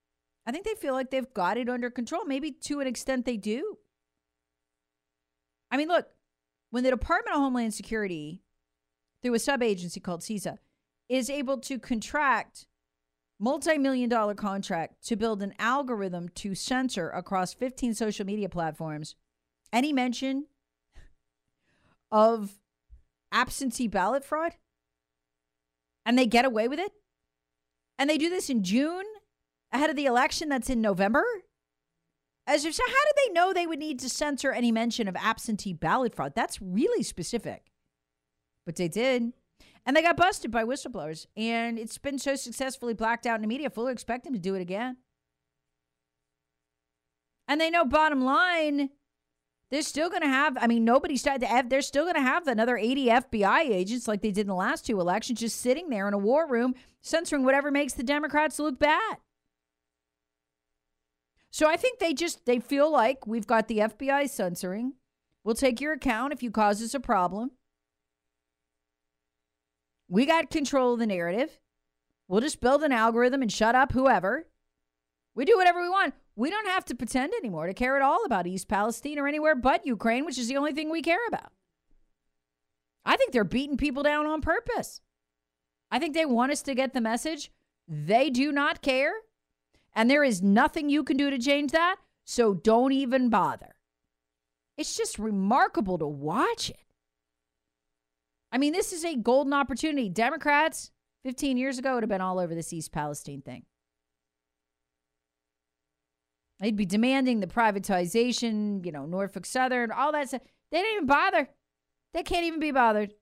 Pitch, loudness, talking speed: 235 Hz, -27 LUFS, 165 wpm